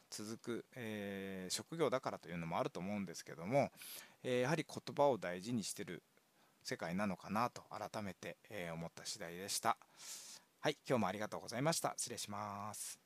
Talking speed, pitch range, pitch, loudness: 370 characters per minute, 95-125 Hz, 105 Hz, -42 LUFS